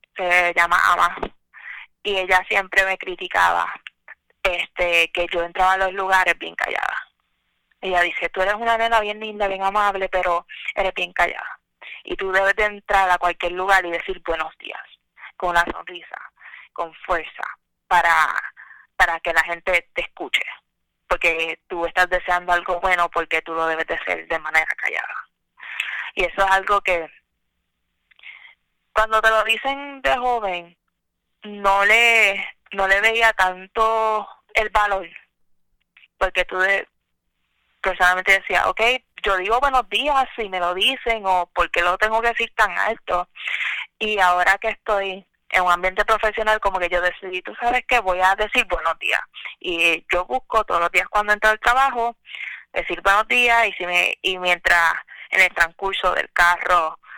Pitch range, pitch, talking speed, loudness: 175-220 Hz, 190 Hz, 160 wpm, -19 LUFS